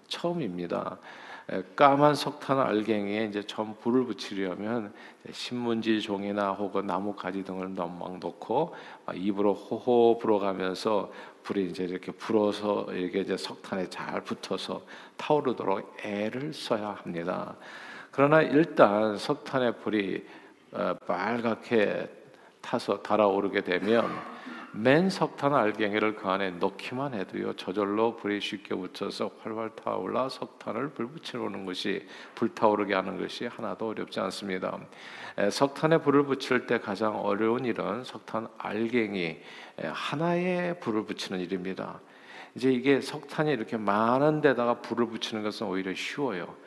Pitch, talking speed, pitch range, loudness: 110 Hz, 295 characters per minute, 100-125 Hz, -29 LUFS